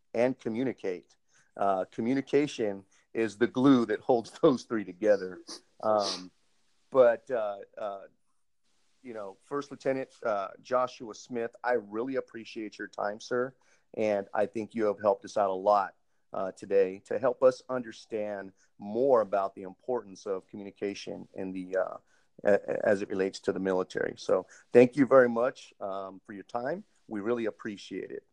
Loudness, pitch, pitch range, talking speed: -30 LUFS, 110 Hz, 95-125 Hz, 155 wpm